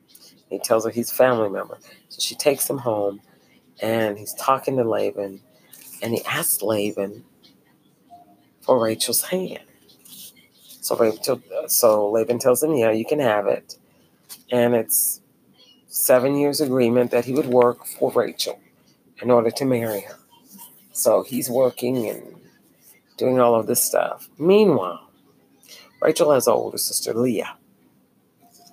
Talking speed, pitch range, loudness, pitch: 140 wpm, 110-135 Hz, -21 LUFS, 120 Hz